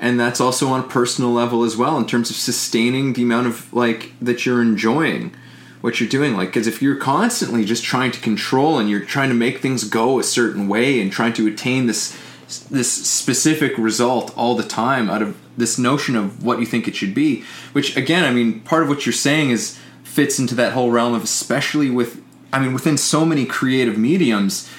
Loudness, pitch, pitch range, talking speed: -18 LUFS, 120 Hz, 115-135 Hz, 215 wpm